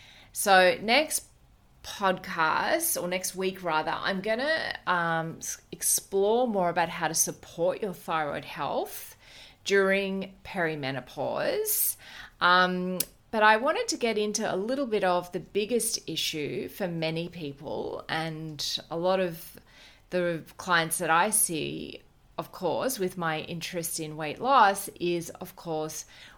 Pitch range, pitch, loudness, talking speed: 160-195 Hz, 180 Hz, -27 LUFS, 130 wpm